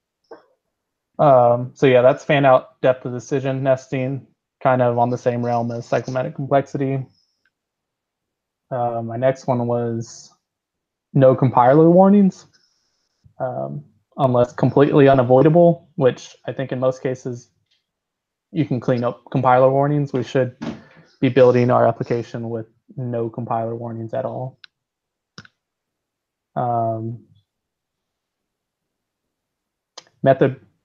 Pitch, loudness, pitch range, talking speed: 130 Hz, -18 LUFS, 120-135 Hz, 110 wpm